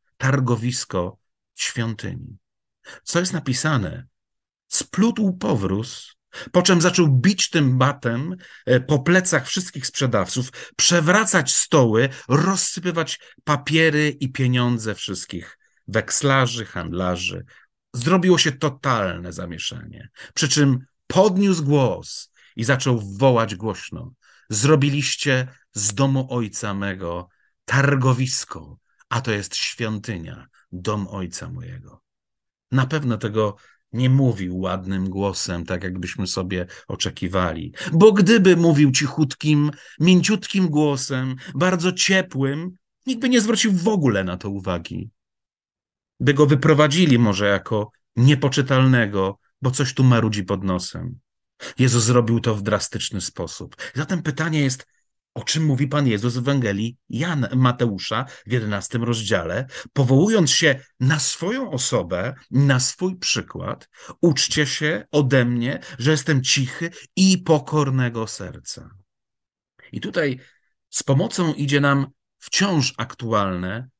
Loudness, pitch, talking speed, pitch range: -20 LUFS, 130 Hz, 115 wpm, 110-150 Hz